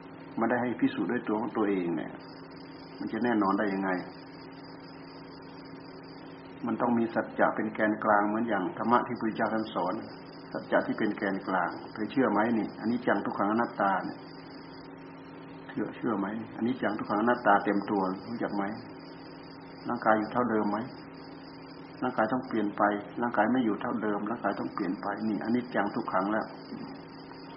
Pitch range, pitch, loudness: 100-120 Hz, 110 Hz, -30 LUFS